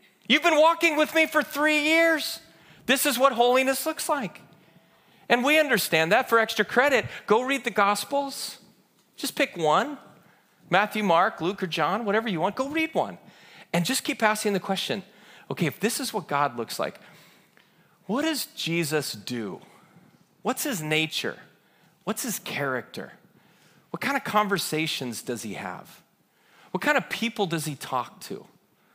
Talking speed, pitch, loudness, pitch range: 160 wpm, 210 Hz, -25 LUFS, 170-275 Hz